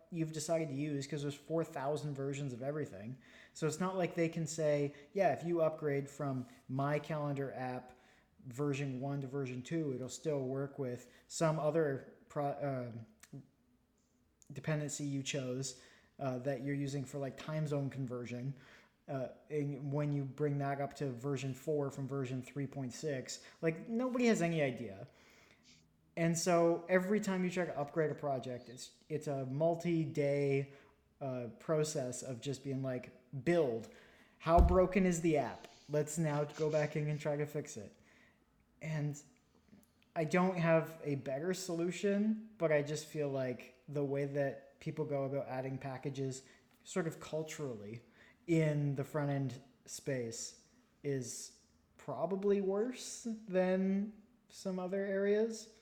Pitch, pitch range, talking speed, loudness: 145 Hz, 135-165 Hz, 150 wpm, -37 LUFS